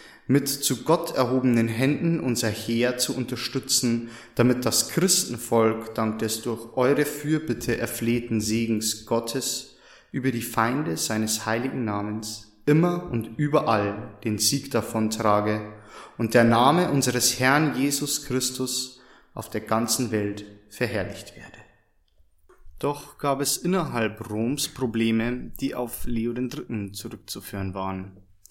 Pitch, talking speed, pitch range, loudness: 120 Hz, 120 wpm, 110-130 Hz, -25 LUFS